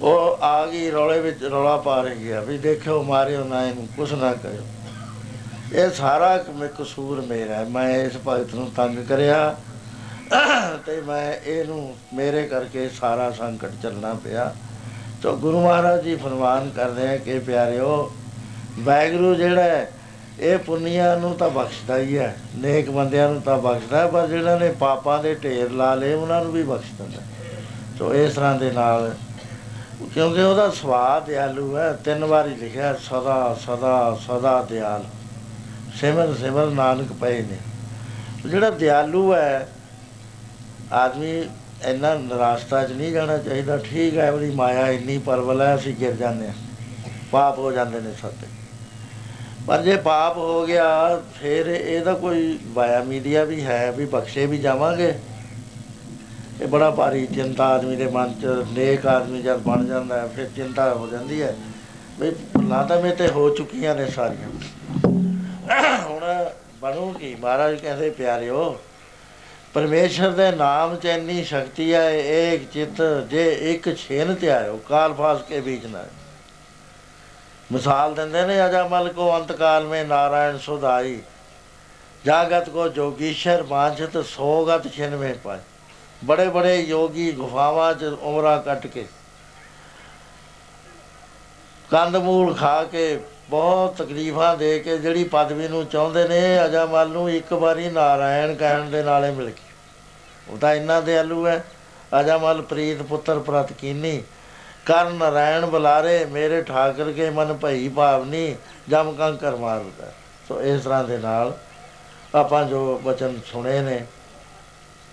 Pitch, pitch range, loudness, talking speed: 140 Hz, 125-160 Hz, -21 LUFS, 140 wpm